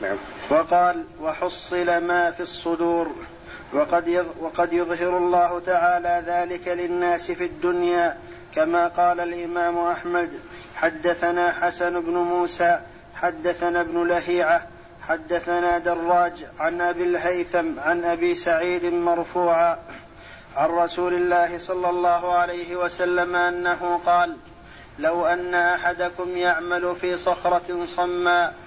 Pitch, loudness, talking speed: 175 Hz, -23 LUFS, 105 wpm